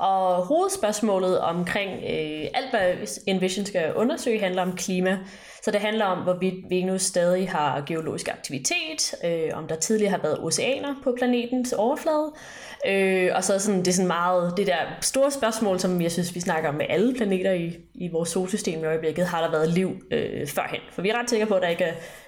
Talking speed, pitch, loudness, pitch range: 205 wpm, 190 Hz, -25 LUFS, 180-220 Hz